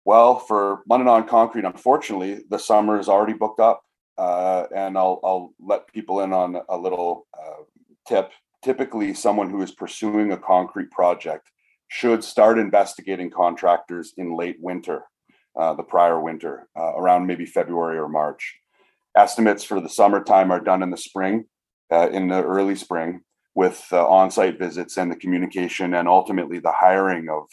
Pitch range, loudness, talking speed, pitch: 90-100 Hz, -20 LUFS, 165 wpm, 95 Hz